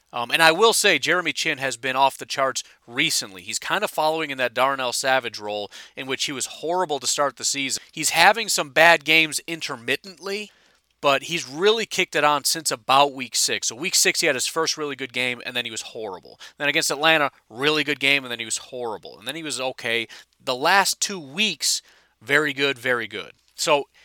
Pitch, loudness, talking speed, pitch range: 145 Hz, -21 LUFS, 215 wpm, 130-165 Hz